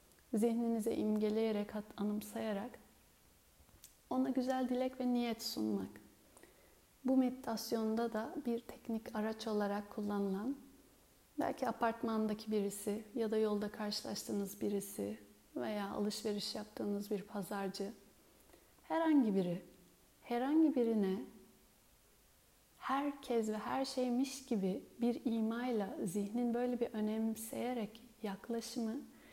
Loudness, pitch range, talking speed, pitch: -38 LUFS, 205-245 Hz, 95 wpm, 225 Hz